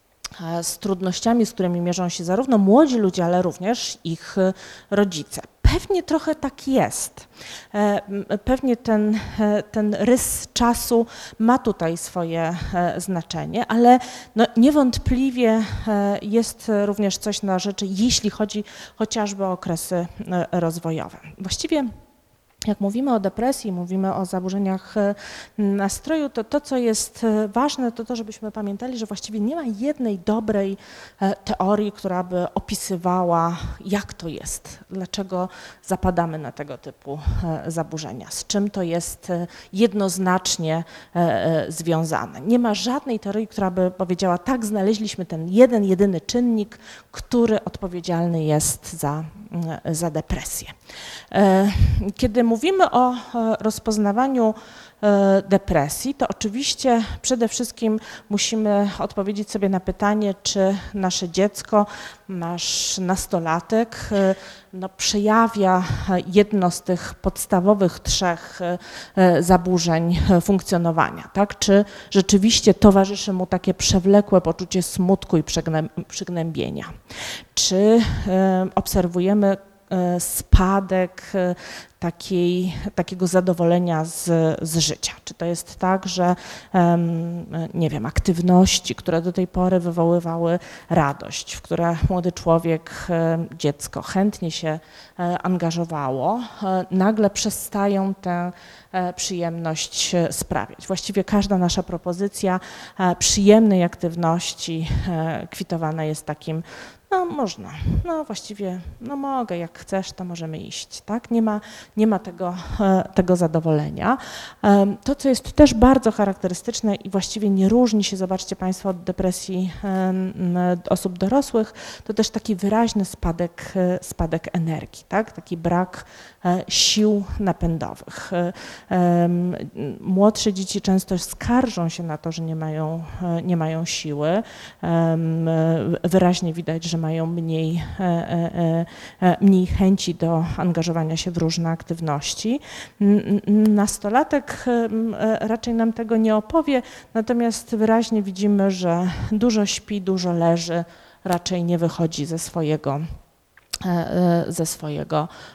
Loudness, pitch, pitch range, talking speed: -21 LUFS, 190 Hz, 170-210 Hz, 110 wpm